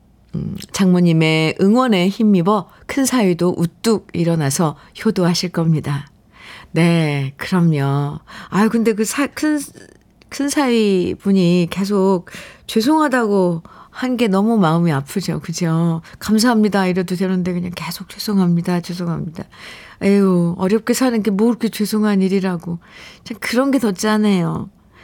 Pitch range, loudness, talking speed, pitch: 170-220 Hz, -17 LUFS, 270 characters per minute, 190 Hz